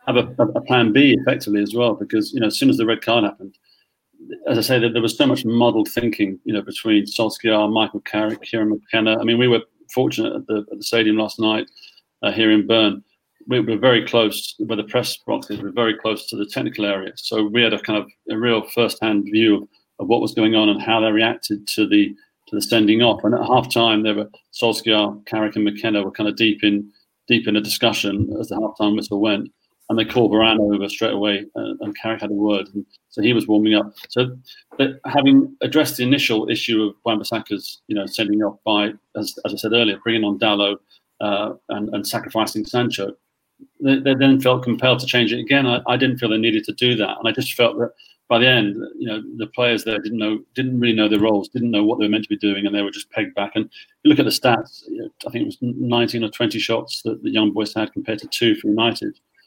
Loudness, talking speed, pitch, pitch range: -19 LUFS, 240 wpm, 110 Hz, 105-125 Hz